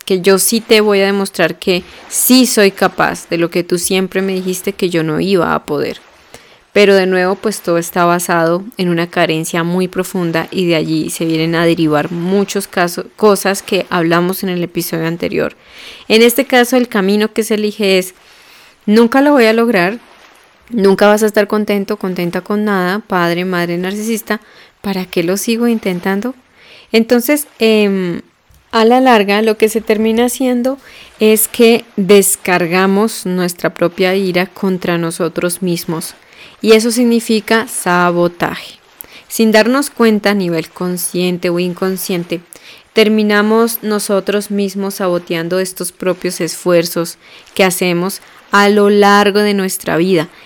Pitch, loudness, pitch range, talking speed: 195 Hz, -13 LUFS, 175-215 Hz, 150 wpm